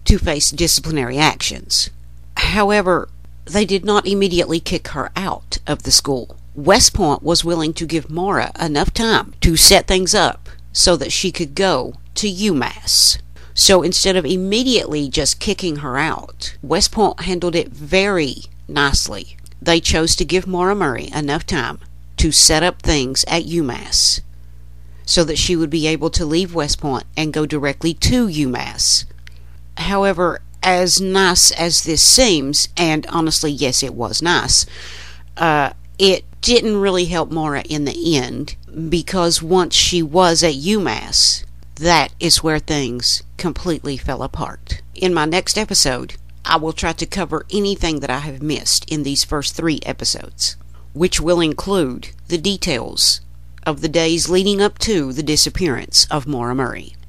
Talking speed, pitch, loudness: 155 wpm, 155 Hz, -16 LUFS